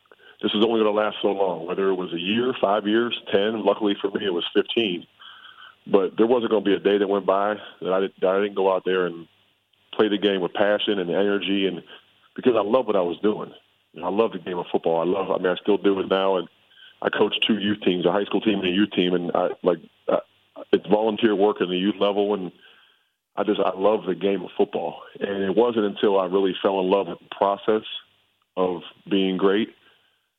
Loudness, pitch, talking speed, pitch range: -23 LUFS, 100 Hz, 235 wpm, 95-105 Hz